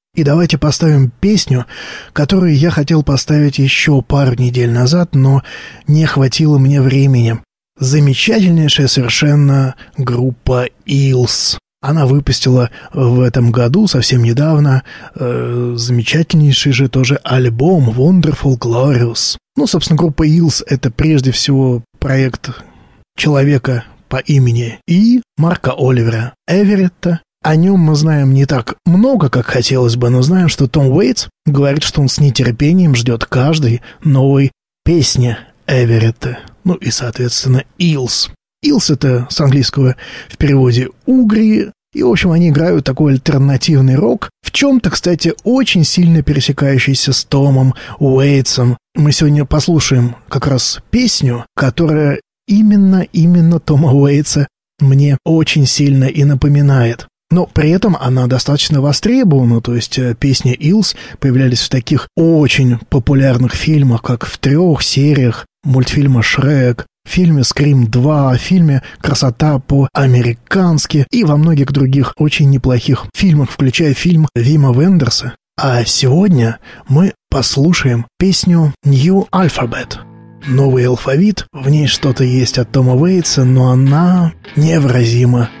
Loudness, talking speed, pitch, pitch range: -12 LUFS, 125 wpm, 140 Hz, 130-155 Hz